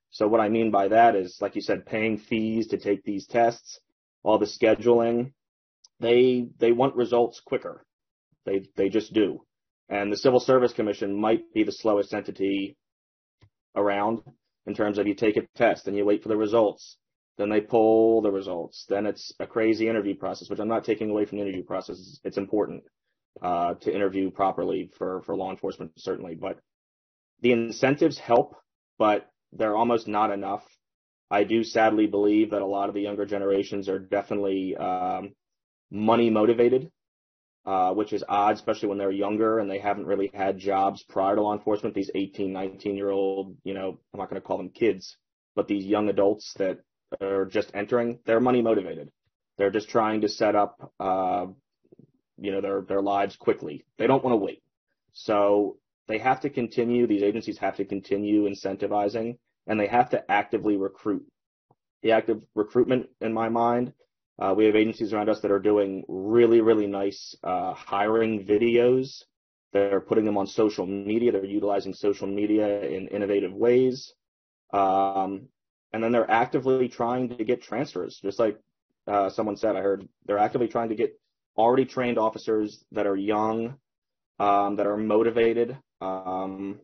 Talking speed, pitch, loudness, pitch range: 175 wpm, 105 Hz, -25 LUFS, 100-115 Hz